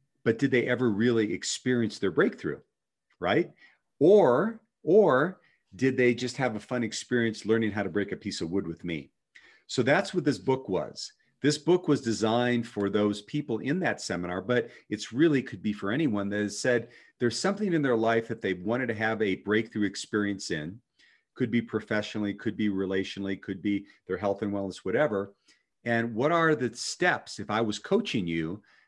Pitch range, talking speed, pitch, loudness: 100-125 Hz, 190 wpm, 110 Hz, -28 LUFS